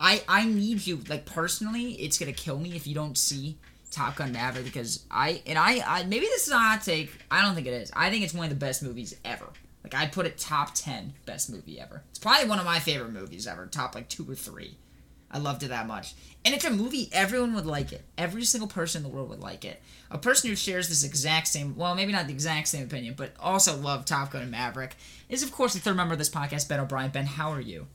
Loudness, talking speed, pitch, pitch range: -27 LUFS, 260 wpm, 160 Hz, 140-195 Hz